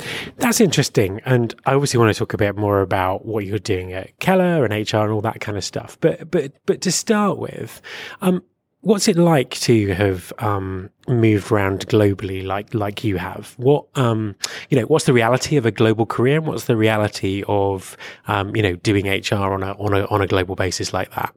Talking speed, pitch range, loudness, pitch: 215 wpm, 100-130 Hz, -19 LUFS, 110 Hz